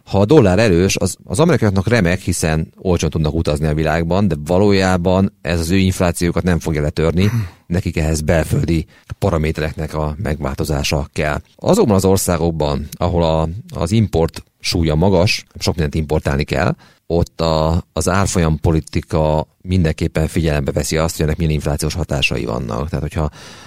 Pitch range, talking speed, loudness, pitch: 80-95 Hz, 150 wpm, -17 LUFS, 85 Hz